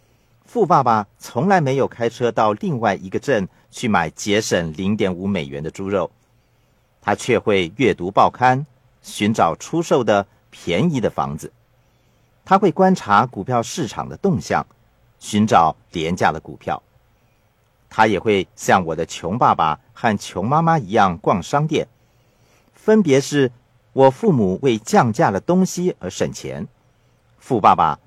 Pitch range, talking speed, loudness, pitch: 105-145 Hz, 210 characters per minute, -19 LUFS, 120 Hz